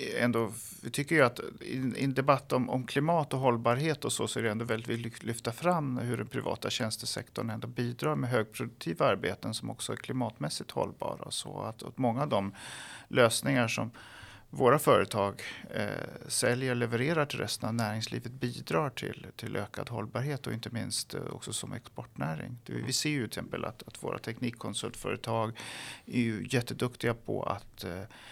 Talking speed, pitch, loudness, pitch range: 175 wpm, 120 Hz, -32 LUFS, 115-130 Hz